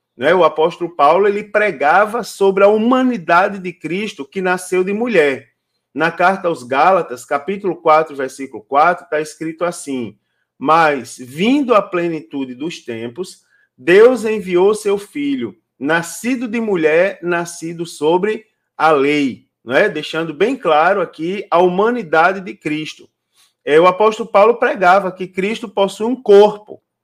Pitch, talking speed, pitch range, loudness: 180 Hz, 135 wpm, 160-210 Hz, -15 LUFS